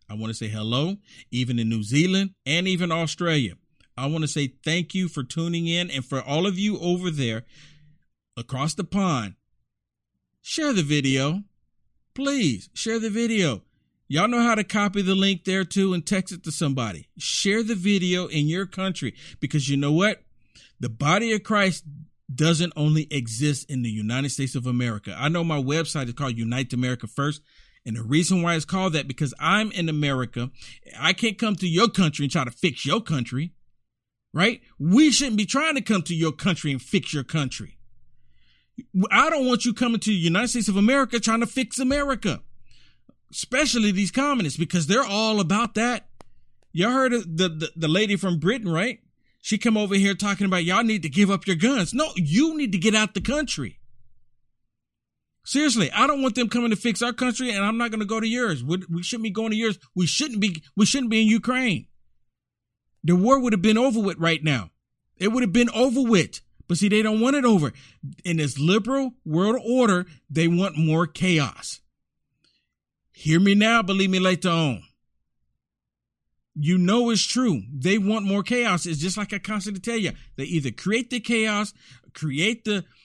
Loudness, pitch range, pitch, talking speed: -23 LUFS, 145-220 Hz, 180 Hz, 195 wpm